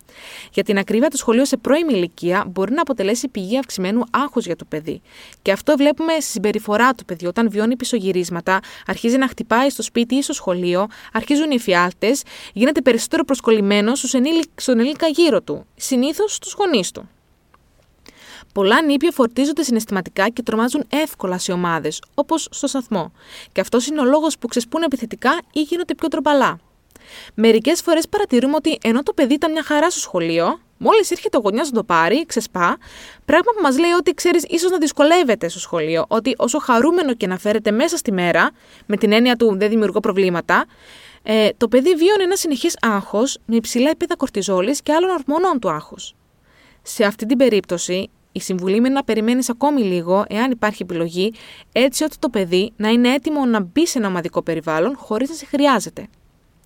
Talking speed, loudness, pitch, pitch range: 175 wpm, -18 LUFS, 245 Hz, 200-300 Hz